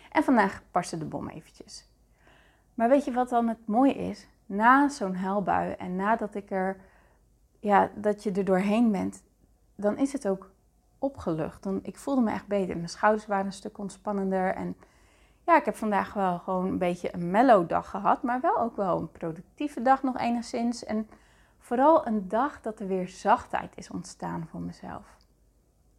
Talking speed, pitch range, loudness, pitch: 180 wpm, 190-240 Hz, -27 LUFS, 210 Hz